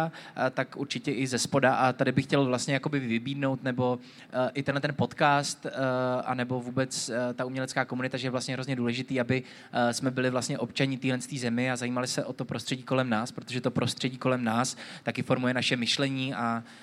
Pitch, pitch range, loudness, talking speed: 130 Hz, 125-135 Hz, -29 LUFS, 210 wpm